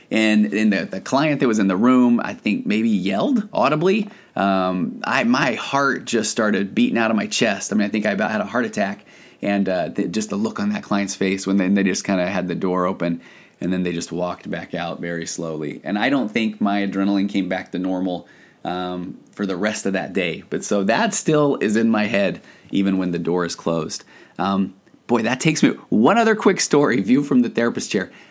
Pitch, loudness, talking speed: 100 Hz, -20 LUFS, 235 wpm